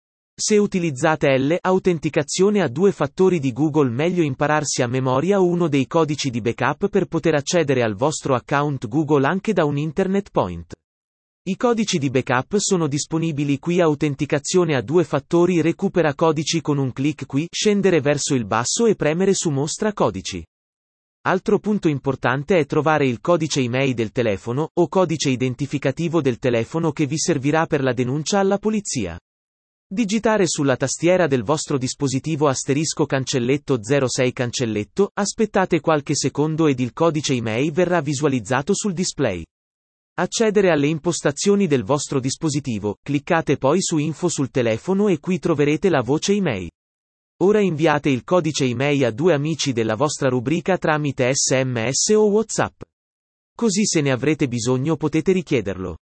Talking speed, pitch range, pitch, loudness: 150 wpm, 135-175 Hz, 150 Hz, -20 LUFS